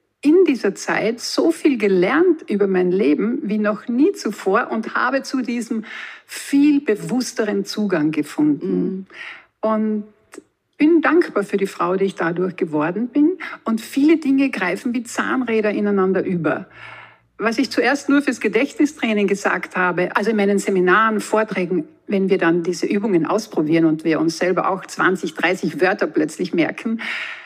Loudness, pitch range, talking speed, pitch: -19 LUFS, 190-275 Hz, 150 wpm, 220 Hz